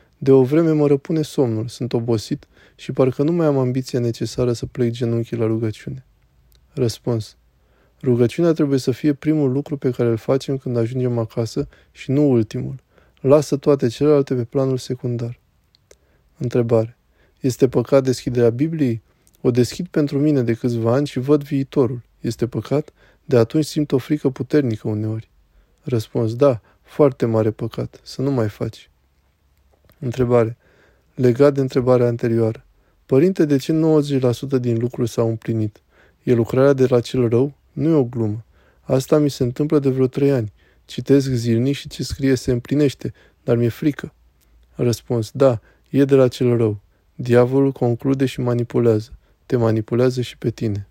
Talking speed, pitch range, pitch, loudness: 155 wpm, 115-140 Hz, 125 Hz, -19 LUFS